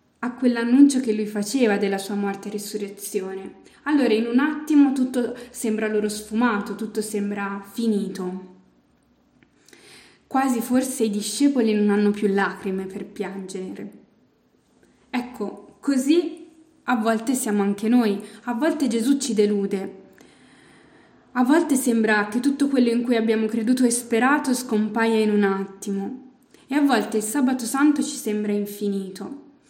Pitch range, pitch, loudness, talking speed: 205-260 Hz, 225 Hz, -22 LUFS, 135 wpm